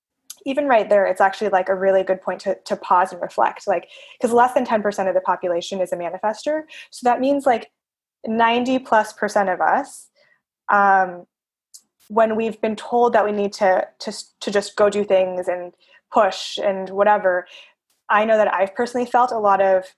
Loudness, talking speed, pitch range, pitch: -19 LUFS, 190 wpm, 190-235 Hz, 205 Hz